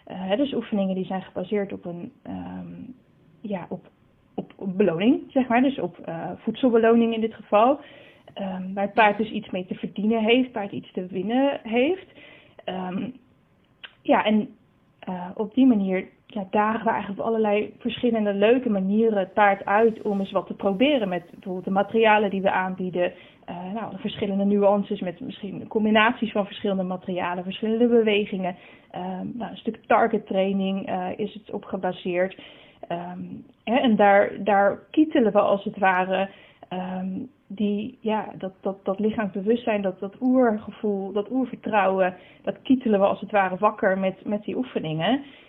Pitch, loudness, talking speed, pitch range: 205 Hz, -24 LUFS, 165 wpm, 190-225 Hz